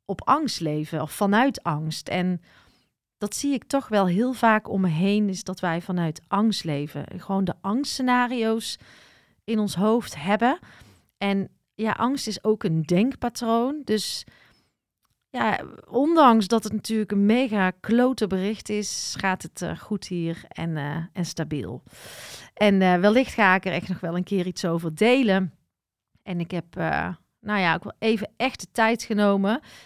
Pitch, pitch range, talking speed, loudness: 200 Hz, 175-225 Hz, 170 wpm, -24 LUFS